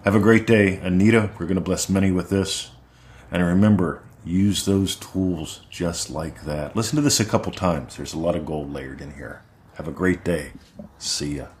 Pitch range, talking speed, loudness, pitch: 80-100 Hz, 205 wpm, -22 LUFS, 95 Hz